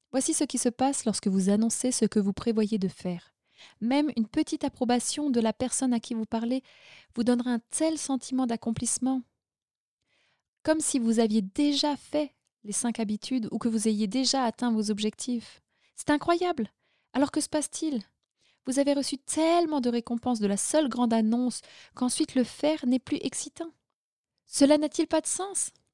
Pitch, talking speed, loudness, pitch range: 255 Hz, 175 wpm, -28 LUFS, 230-295 Hz